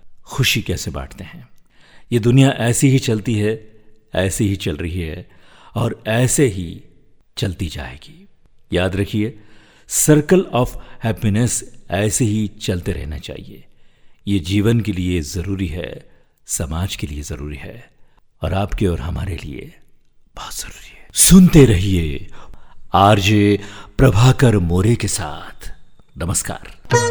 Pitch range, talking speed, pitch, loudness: 90-120 Hz, 125 wpm, 105 Hz, -17 LUFS